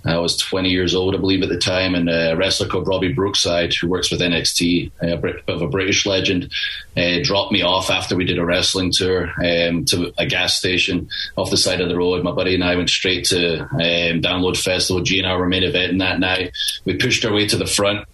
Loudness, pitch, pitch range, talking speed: -18 LUFS, 90 Hz, 85-95 Hz, 240 wpm